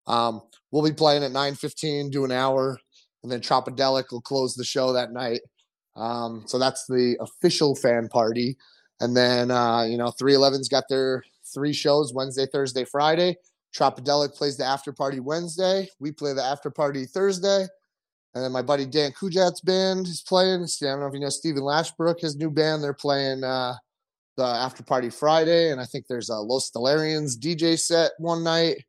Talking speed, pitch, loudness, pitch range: 185 wpm, 140 Hz, -24 LUFS, 130-155 Hz